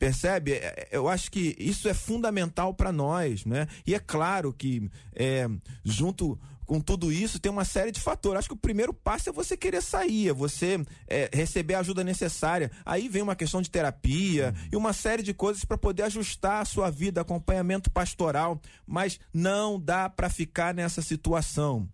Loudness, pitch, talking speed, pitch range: -29 LUFS, 175 Hz, 185 wpm, 150-195 Hz